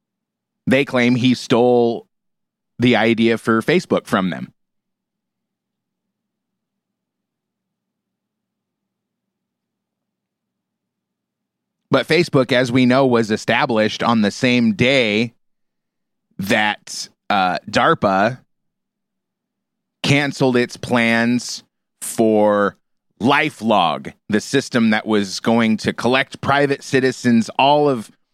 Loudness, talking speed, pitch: -17 LUFS, 85 wpm, 140 Hz